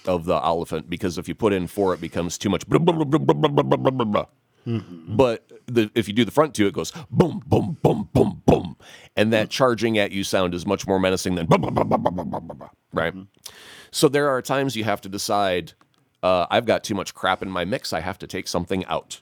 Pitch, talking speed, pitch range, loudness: 100 Hz, 195 wpm, 90-120 Hz, -22 LUFS